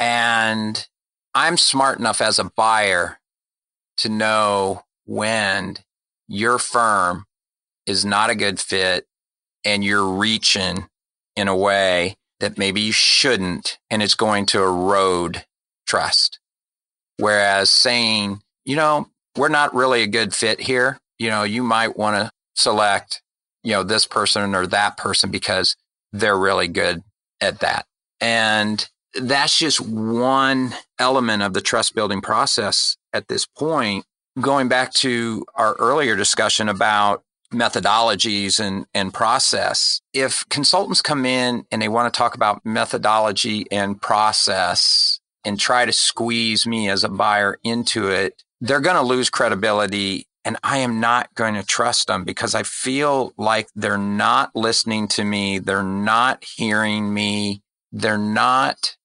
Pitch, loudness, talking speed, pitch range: 110 Hz, -18 LUFS, 140 wpm, 100-120 Hz